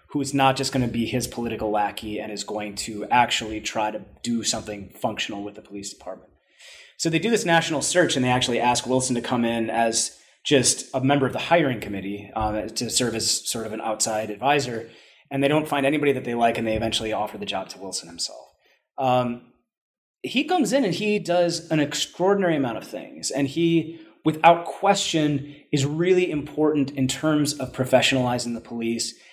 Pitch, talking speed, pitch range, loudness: 125 Hz, 195 wpm, 110-150 Hz, -23 LUFS